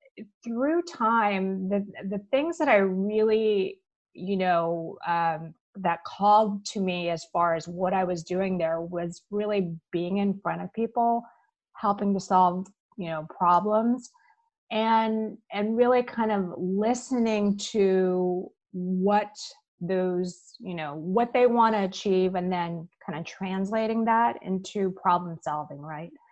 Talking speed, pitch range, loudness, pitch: 140 wpm, 180-220 Hz, -26 LUFS, 195 Hz